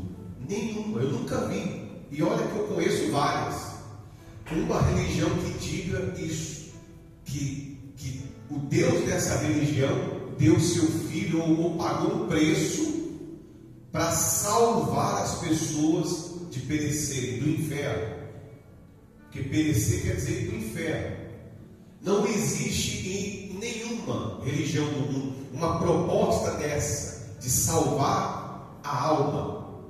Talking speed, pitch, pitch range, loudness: 110 wpm, 150 Hz, 130-170 Hz, -27 LUFS